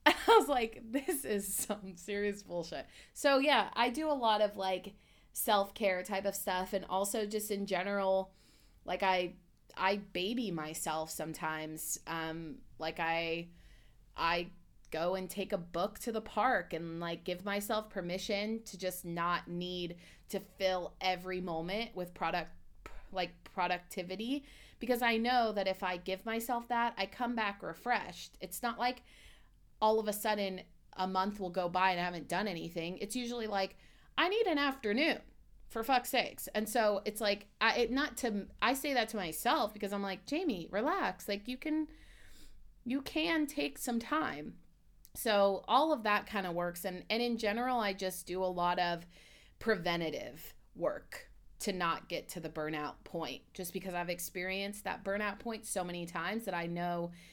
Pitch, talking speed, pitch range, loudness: 195 Hz, 175 wpm, 180-225 Hz, -35 LUFS